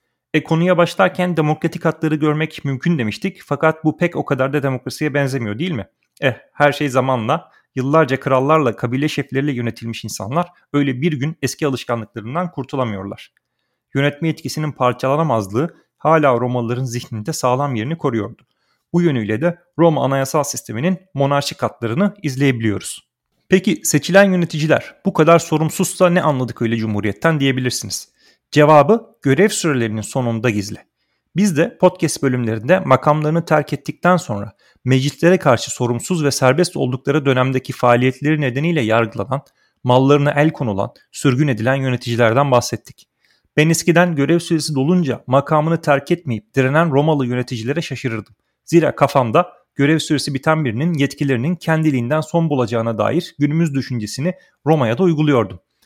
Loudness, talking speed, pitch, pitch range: -17 LUFS, 130 wpm, 145 Hz, 125-160 Hz